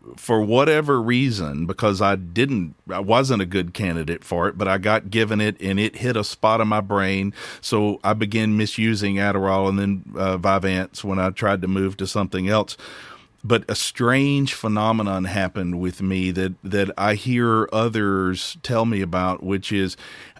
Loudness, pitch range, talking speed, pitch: -21 LUFS, 95-110 Hz, 175 wpm, 100 Hz